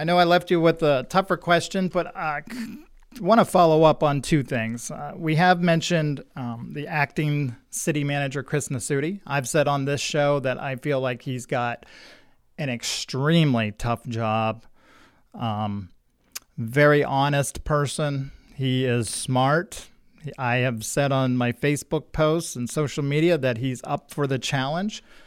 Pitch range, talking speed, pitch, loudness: 130-160 Hz, 160 wpm, 145 Hz, -23 LUFS